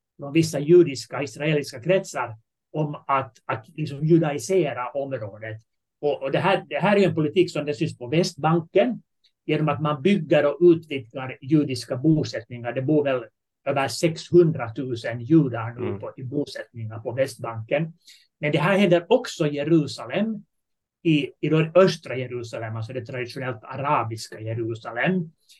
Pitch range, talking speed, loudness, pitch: 125-165 Hz, 150 wpm, -23 LUFS, 145 Hz